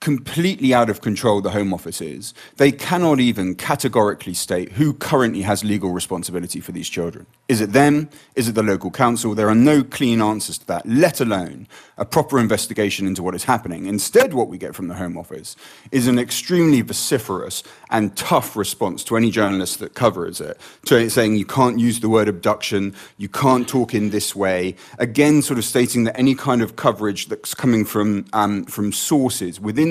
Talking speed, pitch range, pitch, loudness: 195 wpm, 100-130 Hz, 110 Hz, -19 LUFS